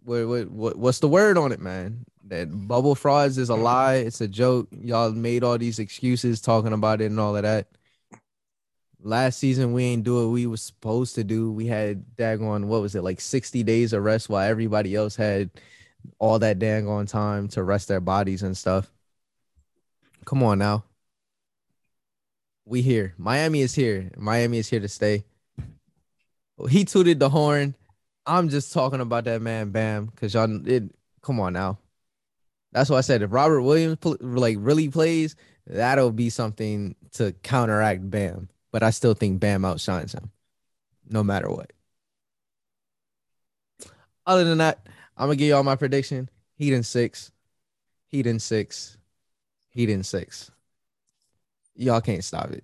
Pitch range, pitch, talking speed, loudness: 105-130 Hz, 115 Hz, 165 wpm, -23 LUFS